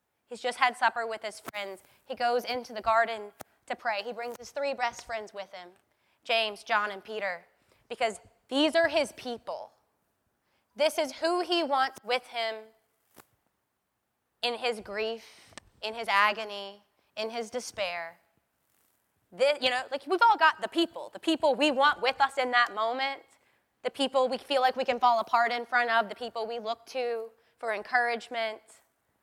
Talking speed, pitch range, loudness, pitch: 170 wpm, 220-260 Hz, -29 LUFS, 235 Hz